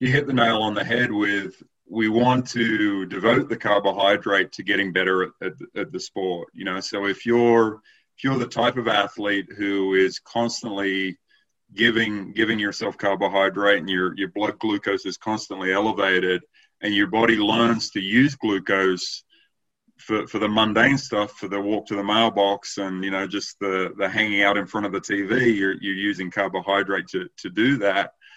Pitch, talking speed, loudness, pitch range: 100 Hz, 185 wpm, -22 LUFS, 100-115 Hz